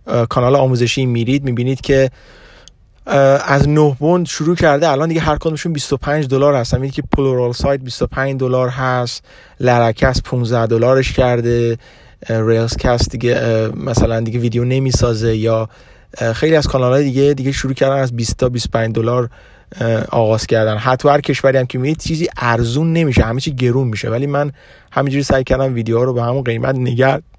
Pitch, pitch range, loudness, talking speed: 130 Hz, 120-140 Hz, -15 LUFS, 165 wpm